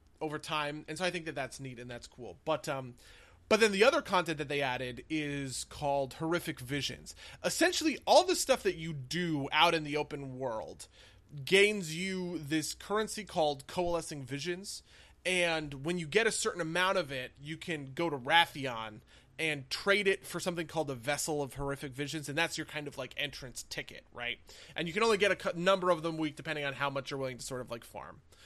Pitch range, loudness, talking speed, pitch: 140-180 Hz, -32 LUFS, 215 wpm, 155 Hz